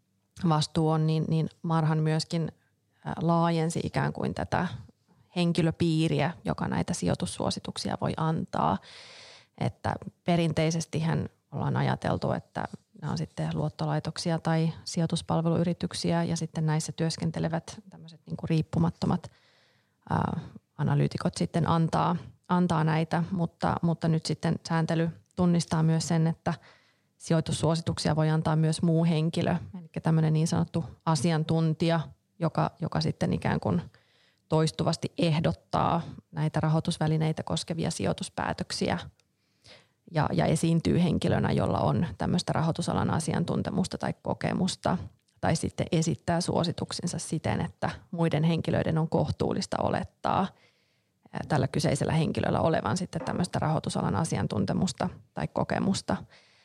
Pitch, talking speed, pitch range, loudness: 165 Hz, 110 wpm, 155-170 Hz, -29 LUFS